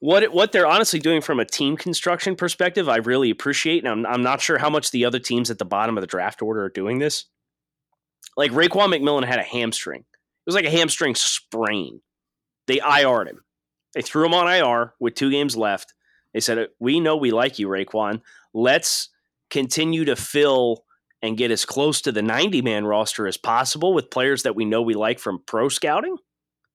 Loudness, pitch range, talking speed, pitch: -21 LUFS, 115-160 Hz, 205 wpm, 130 Hz